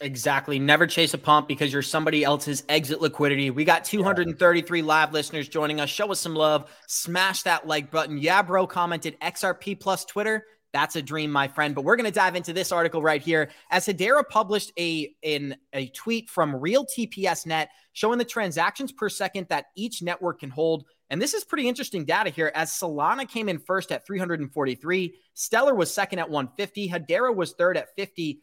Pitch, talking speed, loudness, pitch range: 170 Hz, 190 wpm, -25 LUFS, 150-195 Hz